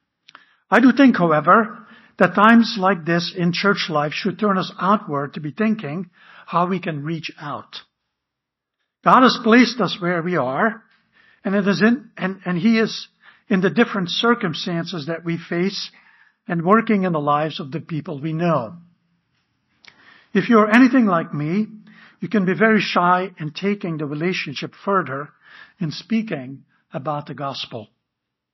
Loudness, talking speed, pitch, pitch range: -19 LUFS, 160 wpm, 185 Hz, 165-215 Hz